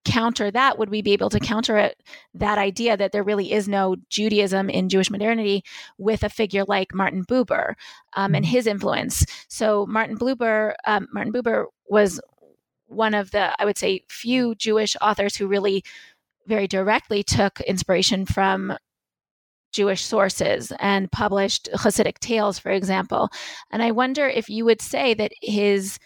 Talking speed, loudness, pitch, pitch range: 160 wpm, -22 LUFS, 210 Hz, 195-225 Hz